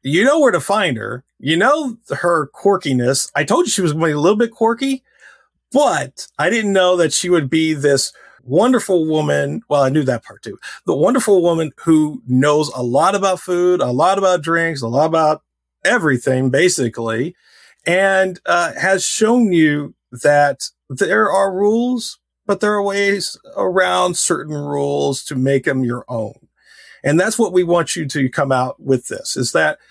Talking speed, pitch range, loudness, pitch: 185 wpm, 135-195 Hz, -16 LUFS, 165 Hz